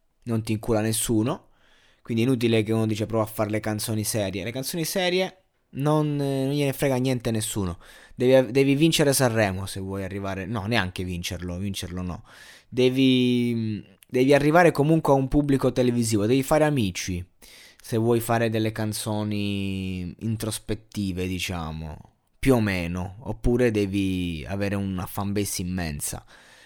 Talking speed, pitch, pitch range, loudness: 145 wpm, 110 Hz, 100-130 Hz, -24 LUFS